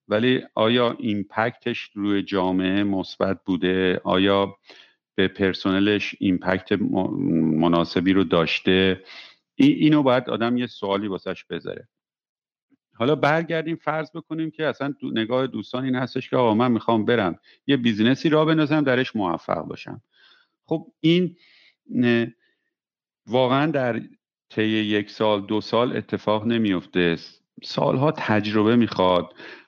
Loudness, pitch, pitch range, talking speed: -22 LUFS, 110 Hz, 95-135 Hz, 120 wpm